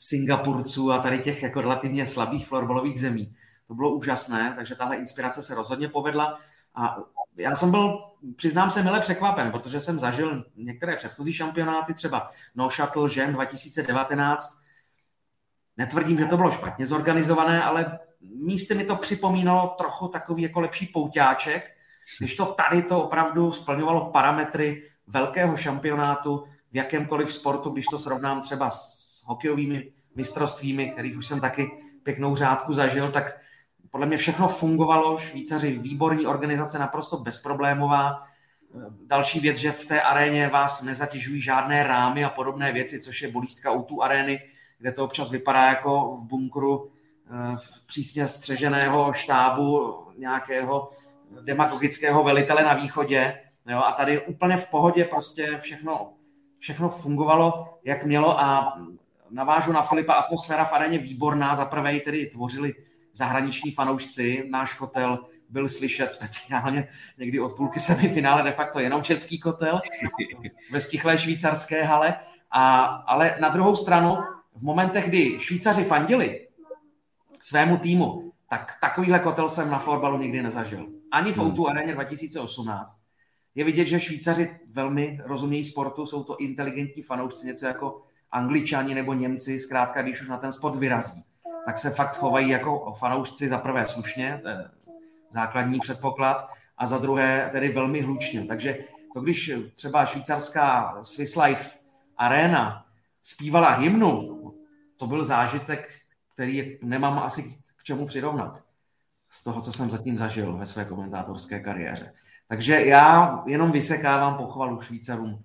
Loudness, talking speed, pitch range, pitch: -24 LUFS, 140 wpm, 130-155 Hz, 145 Hz